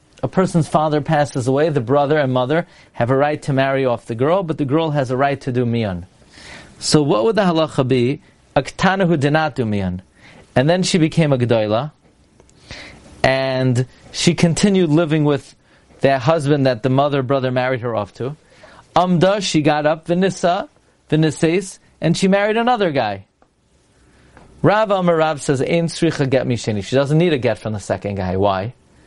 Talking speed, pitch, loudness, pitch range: 165 wpm, 145 Hz, -17 LUFS, 130-165 Hz